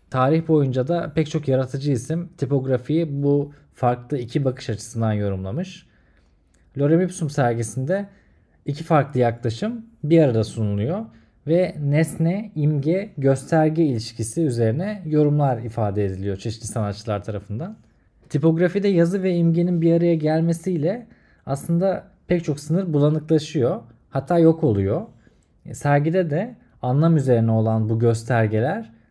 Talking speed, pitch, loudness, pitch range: 120 wpm, 145 Hz, -22 LUFS, 115-165 Hz